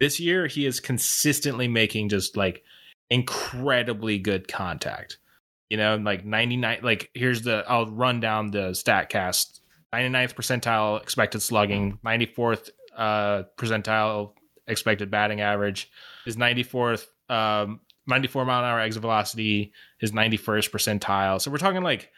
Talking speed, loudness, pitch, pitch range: 135 wpm, -25 LUFS, 110 Hz, 105-125 Hz